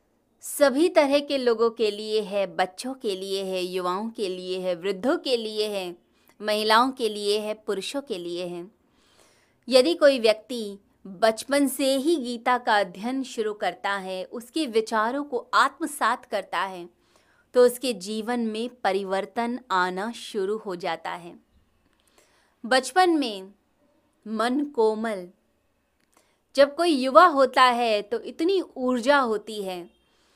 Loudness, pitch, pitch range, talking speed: -24 LUFS, 225 Hz, 200-265 Hz, 135 wpm